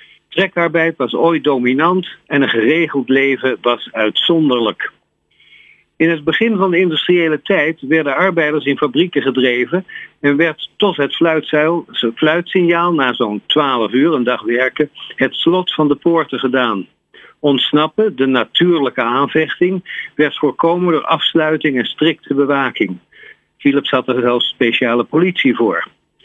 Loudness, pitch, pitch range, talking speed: -15 LUFS, 150 Hz, 130-170 Hz, 135 wpm